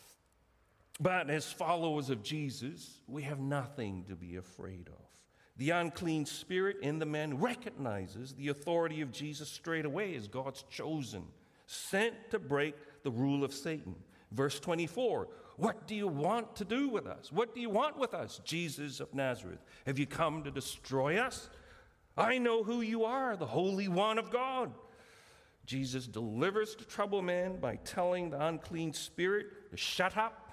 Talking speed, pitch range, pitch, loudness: 165 wpm, 135-195 Hz, 155 Hz, -36 LUFS